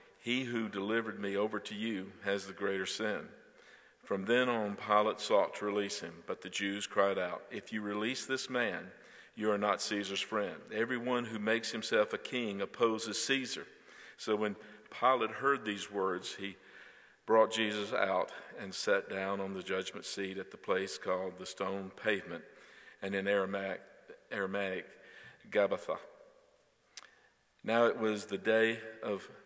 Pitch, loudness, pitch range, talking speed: 105 Hz, -35 LUFS, 100-115 Hz, 155 wpm